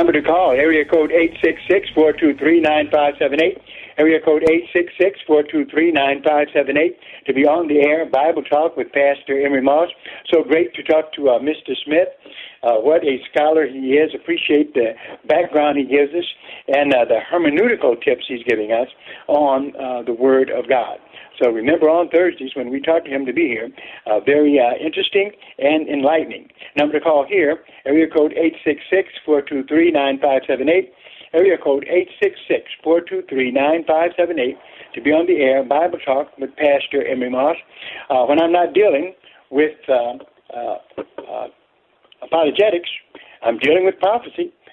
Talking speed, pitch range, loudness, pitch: 190 wpm, 140-170 Hz, -17 LUFS, 155 Hz